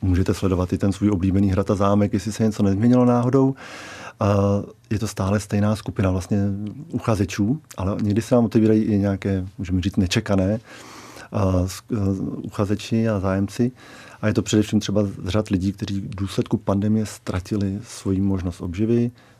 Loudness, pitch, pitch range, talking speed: -22 LUFS, 105 Hz, 100-110 Hz, 150 wpm